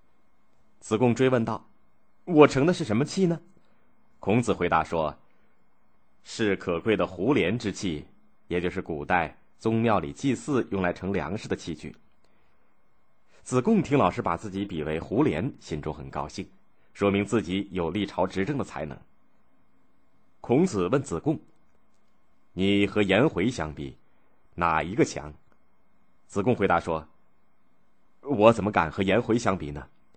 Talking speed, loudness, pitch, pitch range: 205 characters per minute, -26 LUFS, 95 Hz, 85-115 Hz